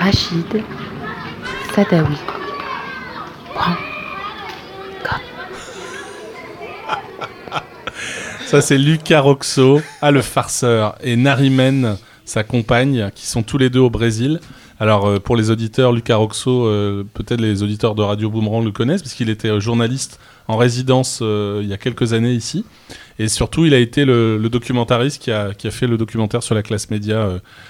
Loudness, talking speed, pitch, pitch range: -17 LUFS, 150 wpm, 120 Hz, 110-135 Hz